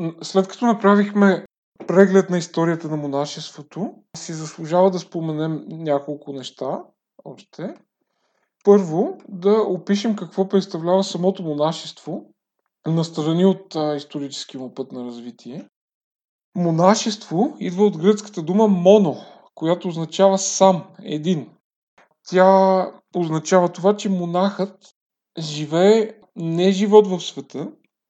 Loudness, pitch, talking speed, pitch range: -19 LUFS, 180 Hz, 105 wpm, 160-195 Hz